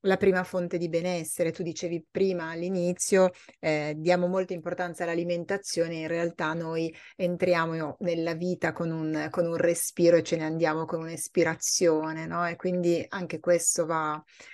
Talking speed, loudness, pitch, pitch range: 155 wpm, -28 LUFS, 170 Hz, 165-180 Hz